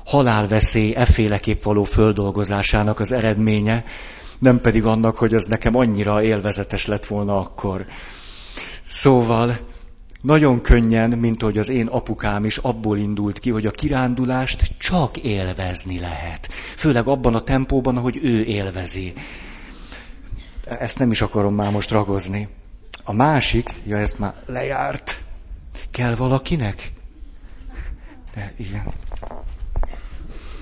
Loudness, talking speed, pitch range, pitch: -19 LUFS, 115 wpm, 100-120 Hz, 105 Hz